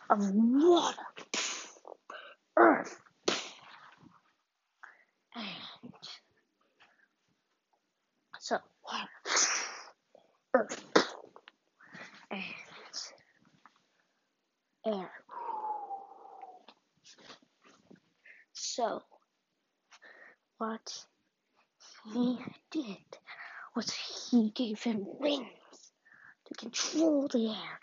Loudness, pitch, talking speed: -33 LUFS, 285 Hz, 45 wpm